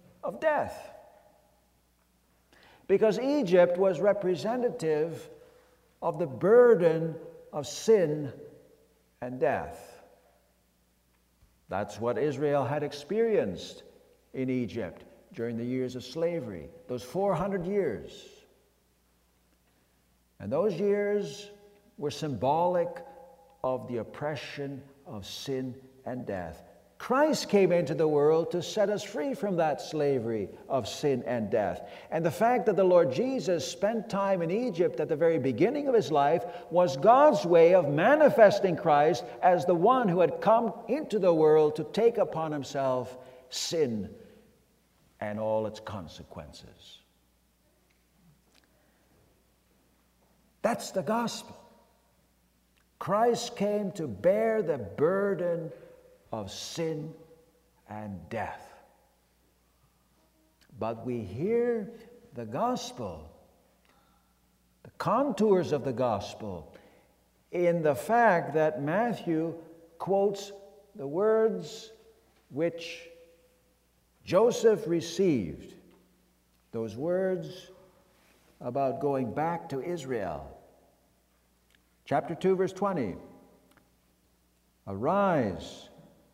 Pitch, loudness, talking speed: 165 Hz, -28 LUFS, 100 wpm